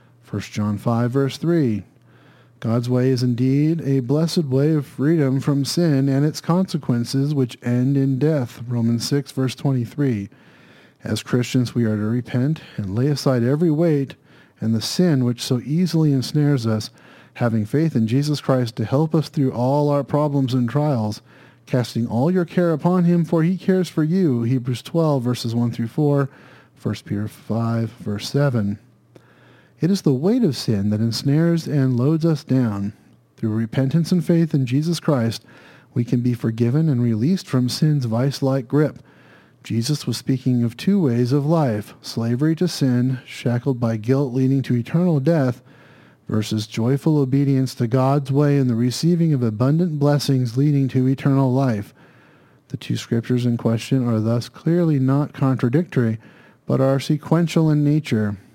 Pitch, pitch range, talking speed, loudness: 135 Hz, 120-150 Hz, 165 wpm, -20 LUFS